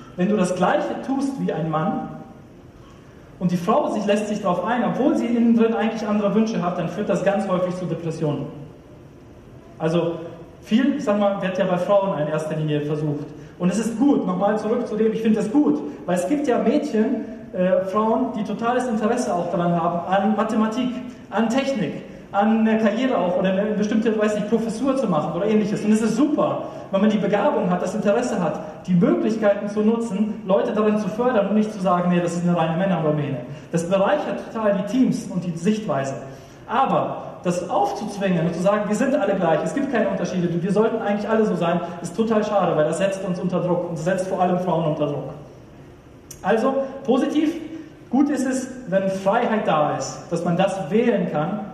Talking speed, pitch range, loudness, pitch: 205 wpm, 180-225 Hz, -21 LUFS, 200 Hz